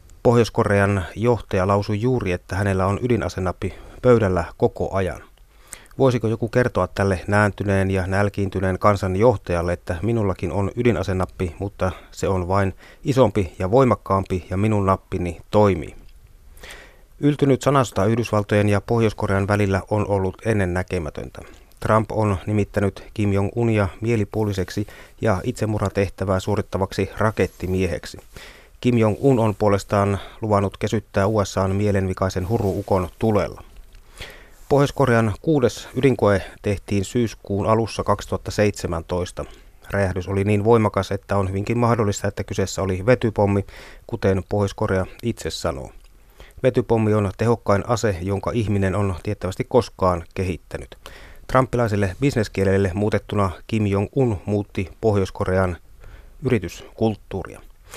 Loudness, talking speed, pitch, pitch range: -21 LUFS, 110 wpm, 100 Hz, 95-110 Hz